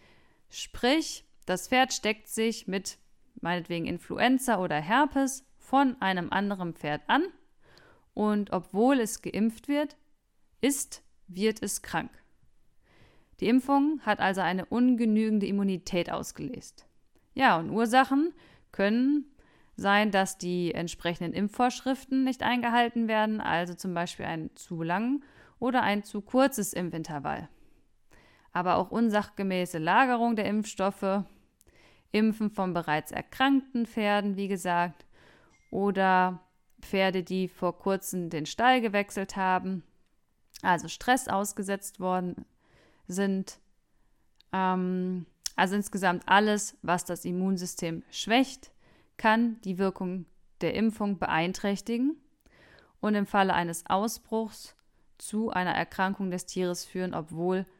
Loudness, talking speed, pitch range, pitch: -28 LUFS, 110 wpm, 185-235 Hz, 200 Hz